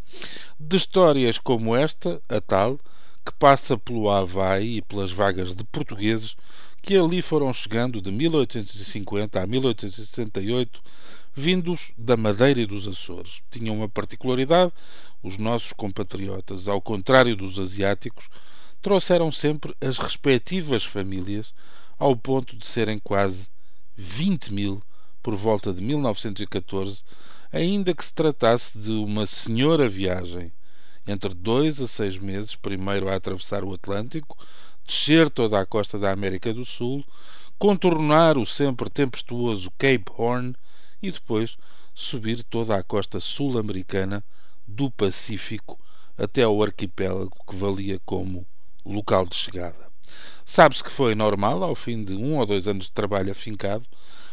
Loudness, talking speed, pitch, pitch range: -24 LUFS, 130 wpm, 110 Hz, 100-130 Hz